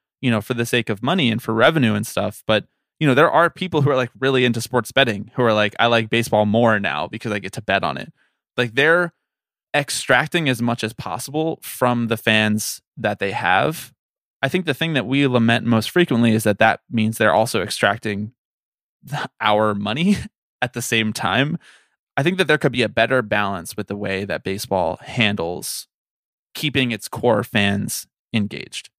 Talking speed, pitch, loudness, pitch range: 195 wpm, 115 Hz, -19 LUFS, 105-130 Hz